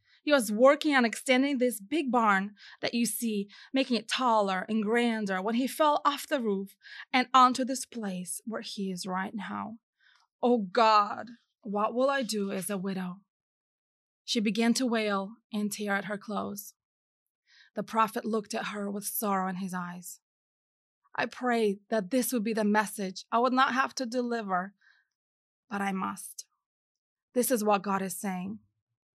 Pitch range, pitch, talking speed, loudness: 195-250 Hz, 220 Hz, 170 wpm, -29 LUFS